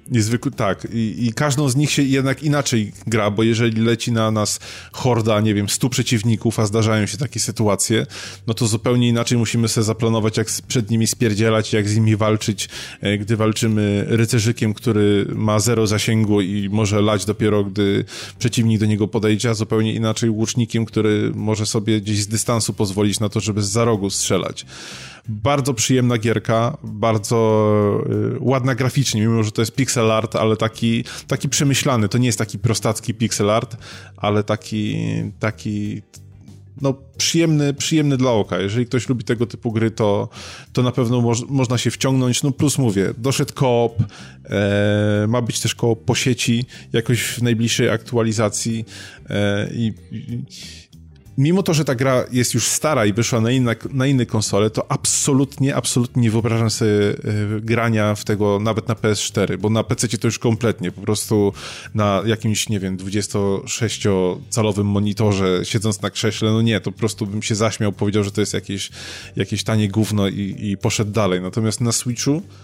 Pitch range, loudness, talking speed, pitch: 105-120 Hz, -19 LUFS, 170 wpm, 110 Hz